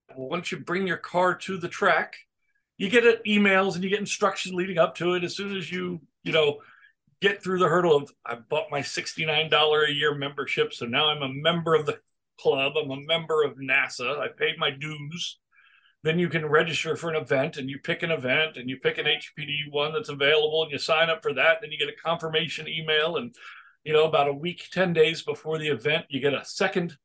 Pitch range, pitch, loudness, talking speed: 150-180 Hz, 160 Hz, -25 LUFS, 225 wpm